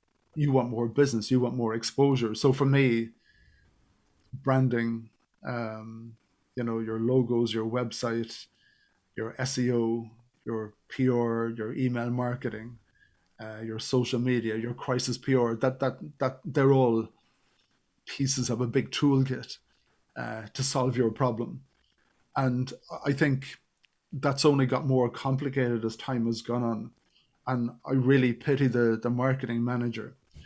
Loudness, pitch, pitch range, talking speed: -28 LUFS, 125 Hz, 115-130 Hz, 130 wpm